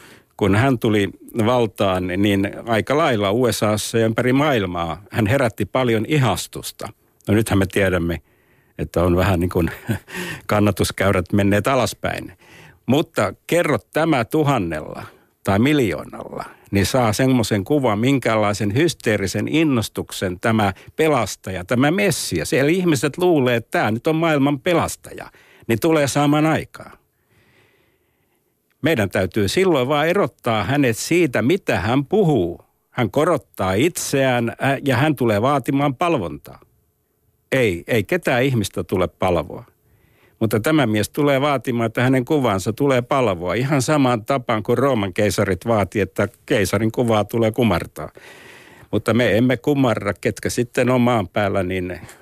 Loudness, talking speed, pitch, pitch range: -19 LUFS, 130 wpm, 115 Hz, 100-140 Hz